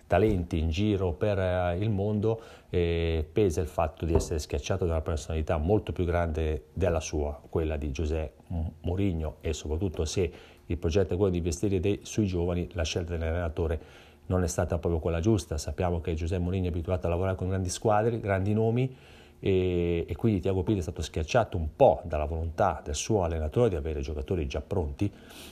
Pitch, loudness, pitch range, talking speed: 90 Hz, -29 LUFS, 80-95 Hz, 185 wpm